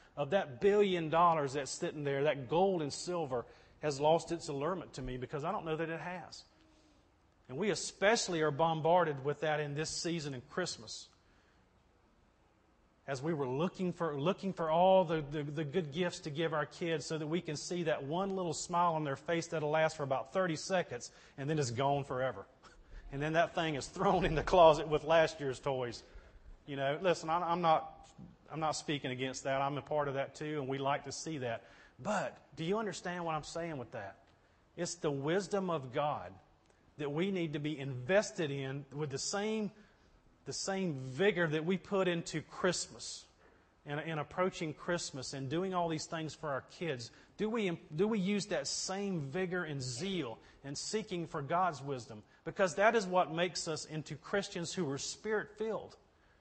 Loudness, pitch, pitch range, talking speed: -35 LUFS, 155 Hz, 140-175 Hz, 195 wpm